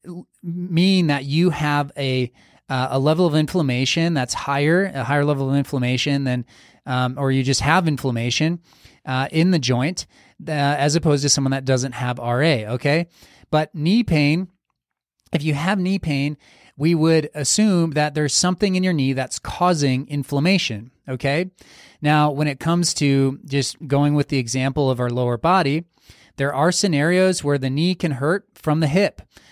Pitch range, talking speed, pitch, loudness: 135-170 Hz, 170 wpm, 145 Hz, -20 LUFS